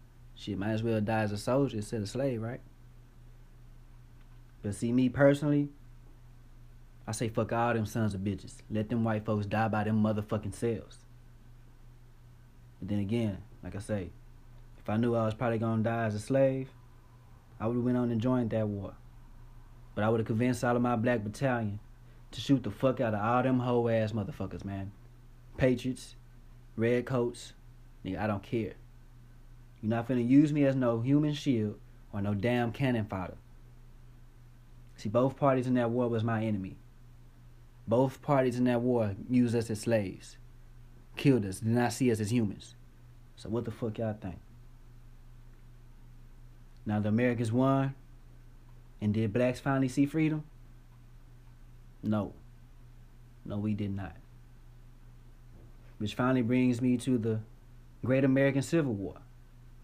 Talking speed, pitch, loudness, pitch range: 160 wpm, 120 Hz, -31 LUFS, 115-120 Hz